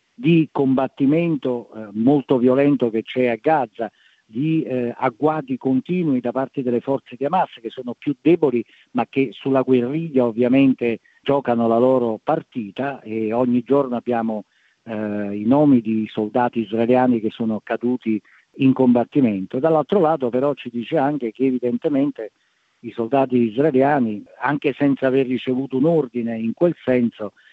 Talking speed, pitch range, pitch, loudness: 150 wpm, 115-140 Hz, 130 Hz, -20 LUFS